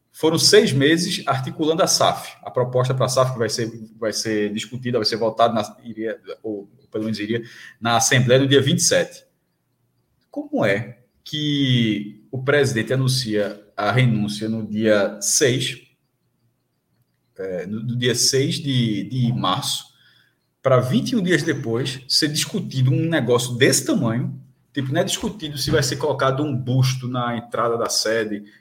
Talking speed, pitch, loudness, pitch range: 150 wpm, 125 Hz, -20 LUFS, 115-140 Hz